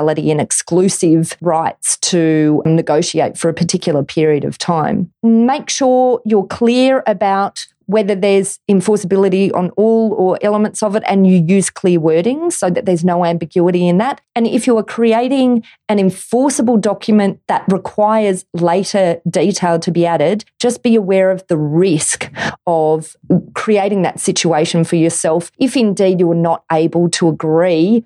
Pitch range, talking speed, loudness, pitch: 170-215 Hz, 155 wpm, -14 LUFS, 190 Hz